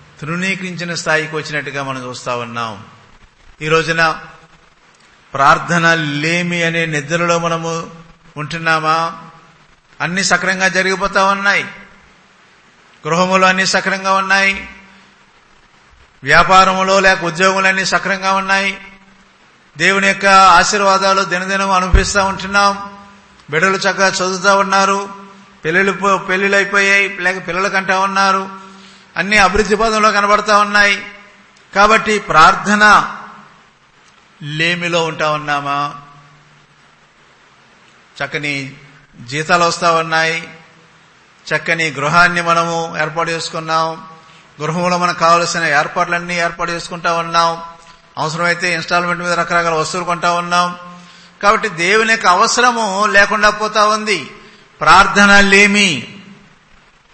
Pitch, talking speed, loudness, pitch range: 175 Hz, 90 wpm, -13 LUFS, 165-195 Hz